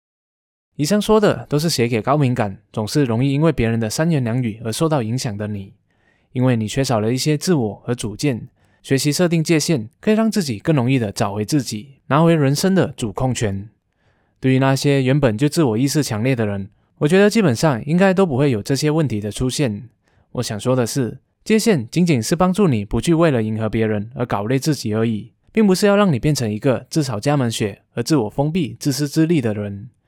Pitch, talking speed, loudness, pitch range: 130 Hz, 315 characters per minute, -18 LUFS, 110-155 Hz